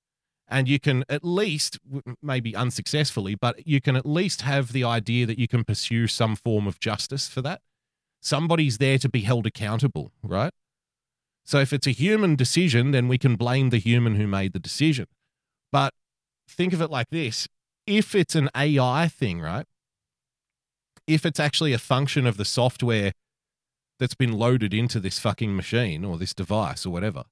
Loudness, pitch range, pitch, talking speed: -24 LUFS, 115-145 Hz, 130 Hz, 175 wpm